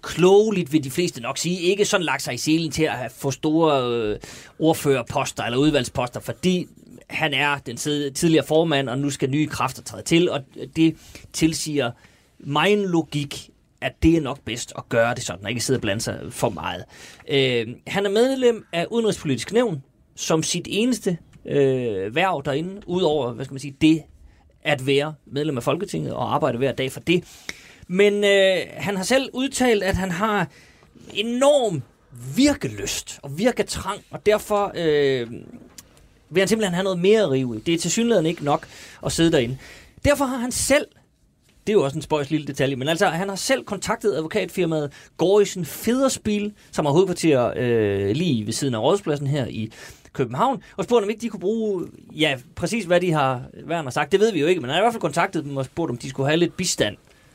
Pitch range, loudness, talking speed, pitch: 135-195 Hz, -22 LUFS, 190 wpm, 155 Hz